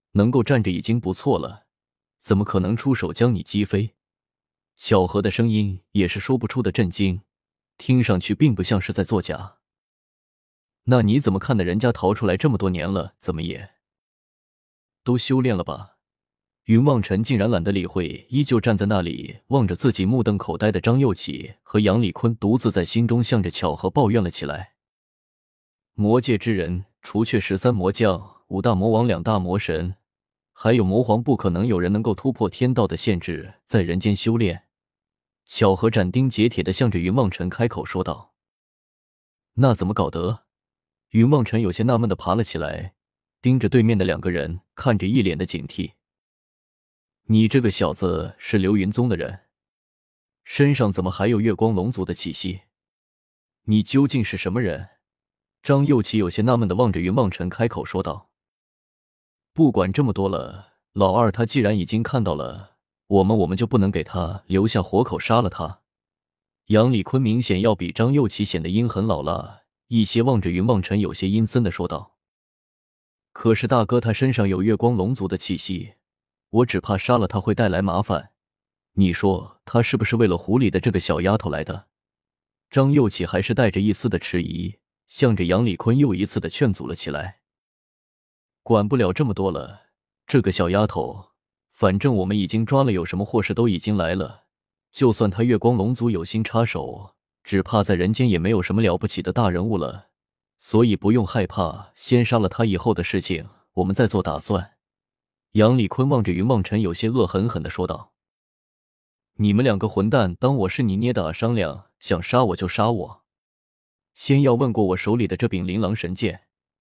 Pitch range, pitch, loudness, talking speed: 95-115 Hz, 105 Hz, -21 LUFS, 260 characters per minute